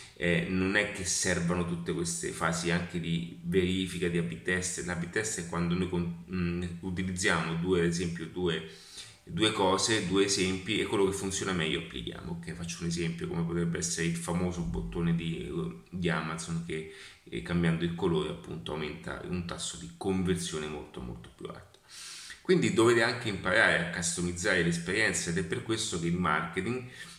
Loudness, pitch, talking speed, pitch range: -31 LUFS, 90 Hz, 165 wpm, 85-95 Hz